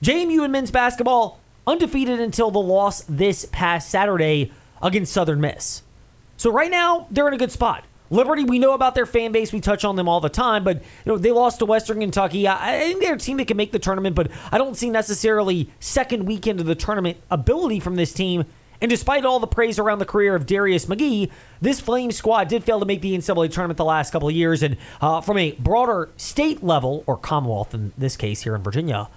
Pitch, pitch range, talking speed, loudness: 200 Hz, 165-235 Hz, 225 wpm, -21 LUFS